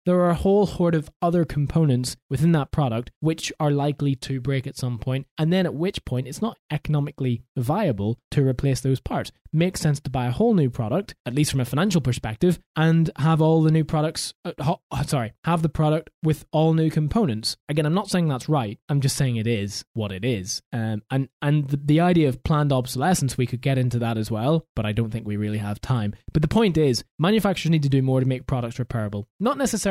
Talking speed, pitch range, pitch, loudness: 235 wpm, 125-160 Hz, 145 Hz, -23 LUFS